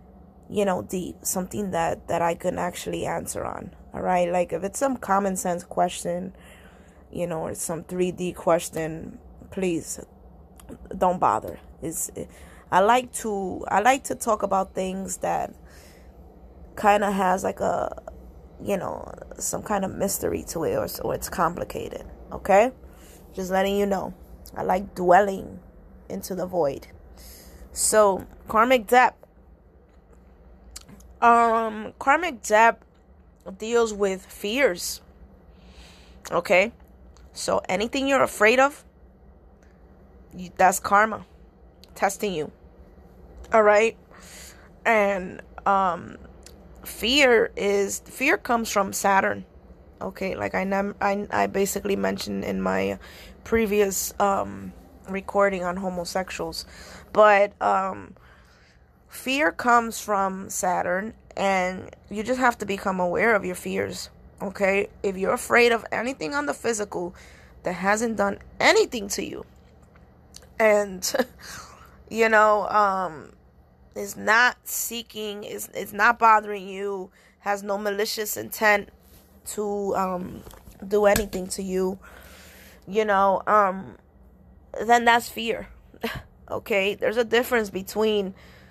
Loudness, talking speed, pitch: -23 LUFS, 120 wpm, 195 Hz